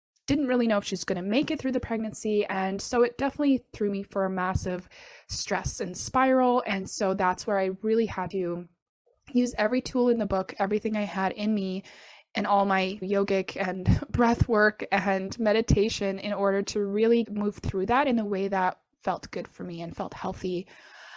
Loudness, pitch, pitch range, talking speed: -27 LUFS, 205 Hz, 190-235 Hz, 195 wpm